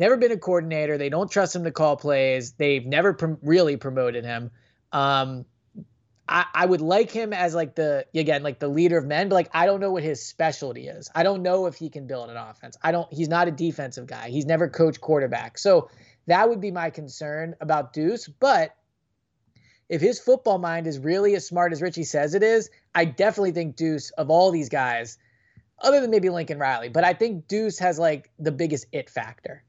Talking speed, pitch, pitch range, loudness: 215 wpm, 165 Hz, 145-180 Hz, -23 LUFS